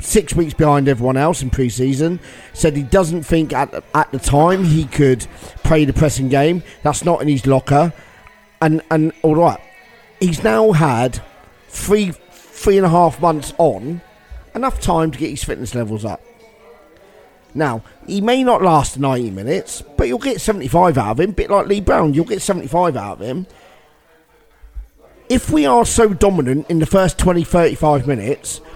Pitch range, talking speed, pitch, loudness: 135-180 Hz, 175 wpm, 160 Hz, -16 LUFS